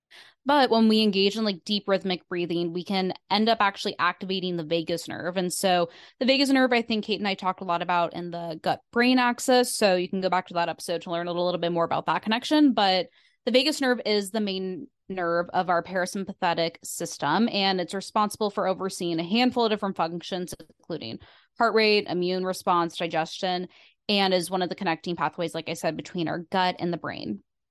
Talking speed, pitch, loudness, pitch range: 210 wpm, 185 Hz, -25 LUFS, 170-210 Hz